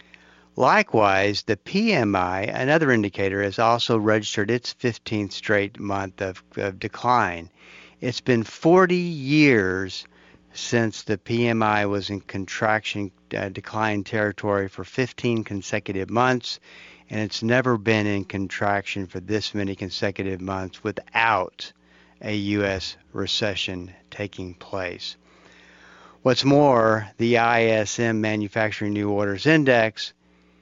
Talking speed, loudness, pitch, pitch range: 110 wpm, -23 LUFS, 105 Hz, 95-115 Hz